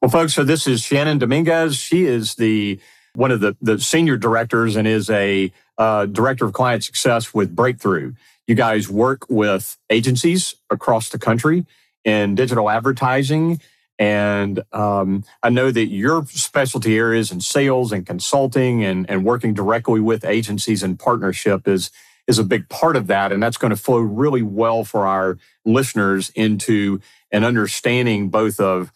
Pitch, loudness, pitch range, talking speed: 115 Hz, -18 LUFS, 105-130 Hz, 165 wpm